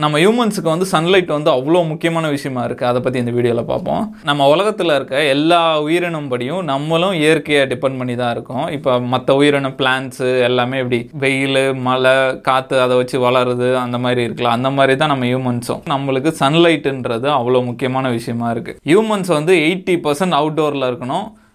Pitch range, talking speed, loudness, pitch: 125-160 Hz, 160 wpm, -16 LUFS, 135 Hz